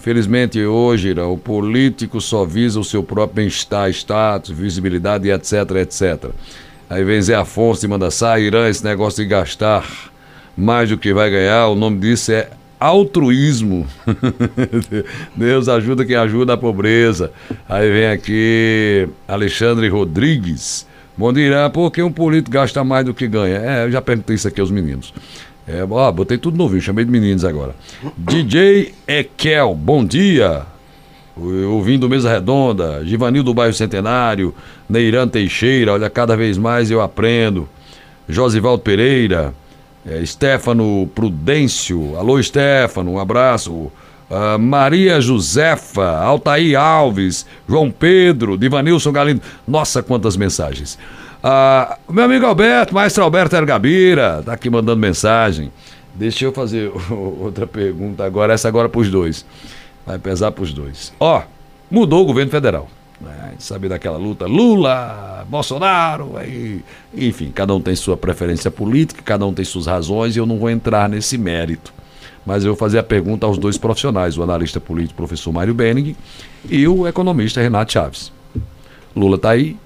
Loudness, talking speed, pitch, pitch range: -15 LUFS, 150 wpm, 110 Hz, 95-130 Hz